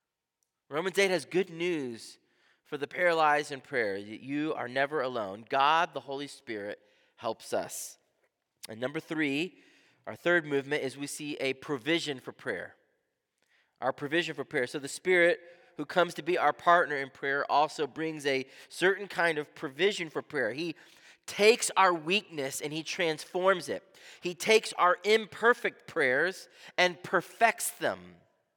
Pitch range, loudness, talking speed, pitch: 145-180 Hz, -30 LUFS, 155 wpm, 160 Hz